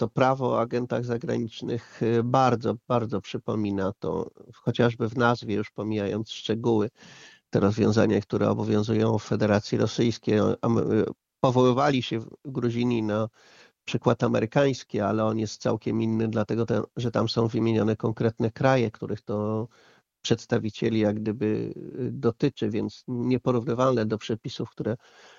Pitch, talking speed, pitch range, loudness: 115 Hz, 125 wpm, 105-120 Hz, -26 LUFS